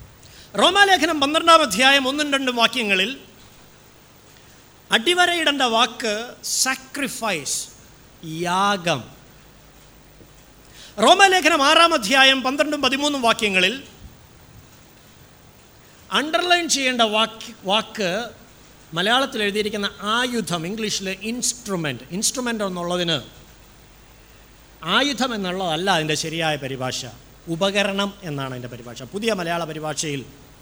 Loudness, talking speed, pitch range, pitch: -19 LUFS, 75 wpm, 165-260 Hz, 210 Hz